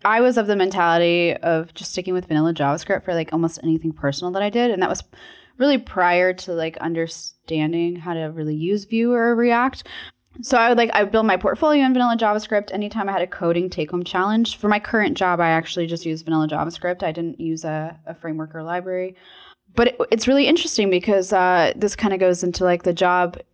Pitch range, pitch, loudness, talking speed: 165-210 Hz, 180 Hz, -20 LUFS, 220 wpm